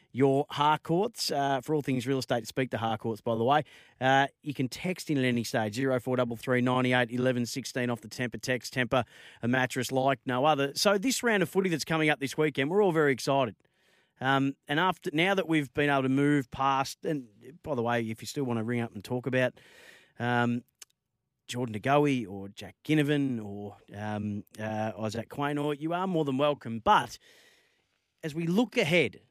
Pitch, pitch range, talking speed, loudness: 135 Hz, 120-150 Hz, 190 wpm, -29 LUFS